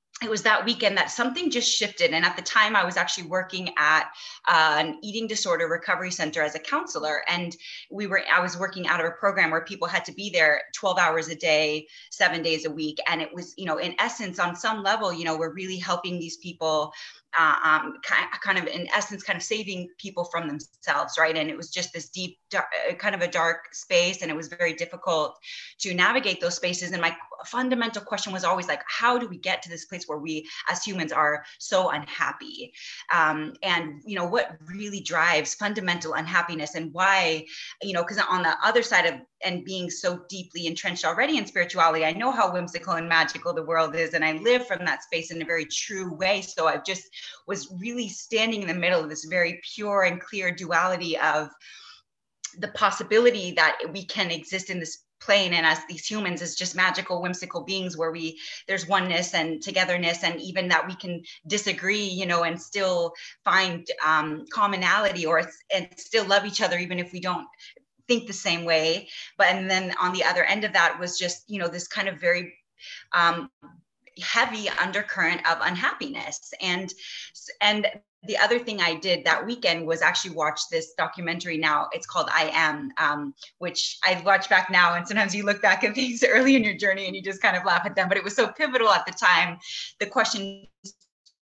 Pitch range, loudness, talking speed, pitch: 165-200 Hz, -24 LUFS, 205 wpm, 180 Hz